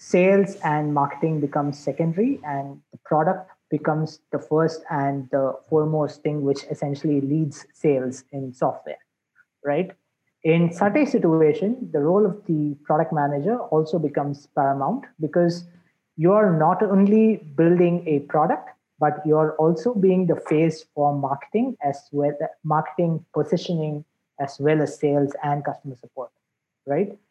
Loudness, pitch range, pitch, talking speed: -22 LUFS, 145-175 Hz, 155 Hz, 140 wpm